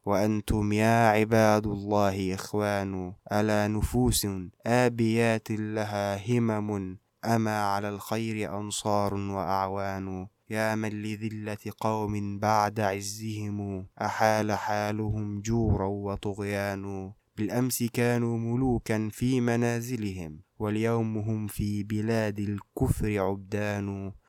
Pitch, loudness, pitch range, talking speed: 105 Hz, -28 LUFS, 100-110 Hz, 90 wpm